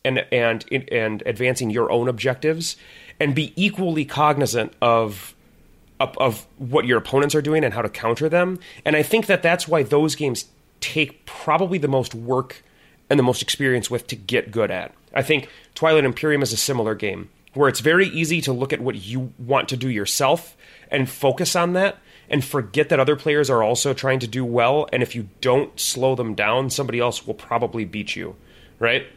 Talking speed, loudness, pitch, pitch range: 200 wpm, -21 LUFS, 135 Hz, 120-150 Hz